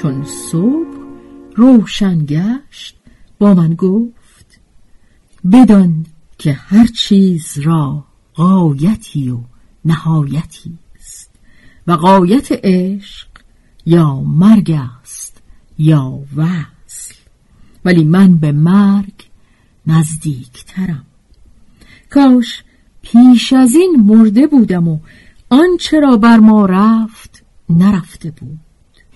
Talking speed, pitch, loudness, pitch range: 90 wpm, 180 Hz, -11 LUFS, 155-220 Hz